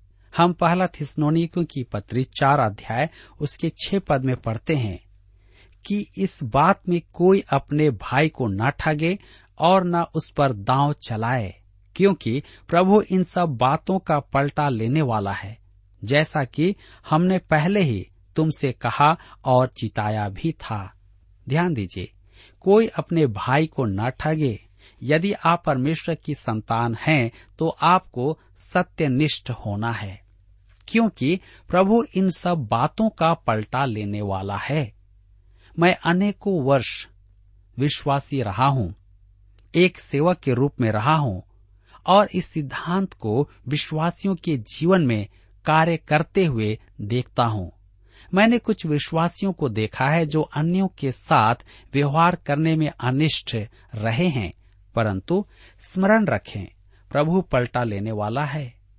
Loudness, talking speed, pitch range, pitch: -22 LUFS, 130 wpm, 105-165 Hz, 140 Hz